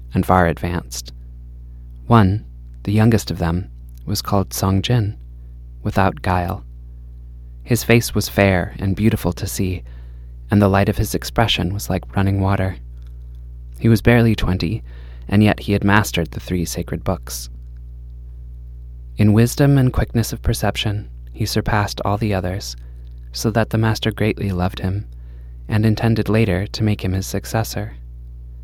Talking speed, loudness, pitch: 150 wpm, -19 LUFS, 90 Hz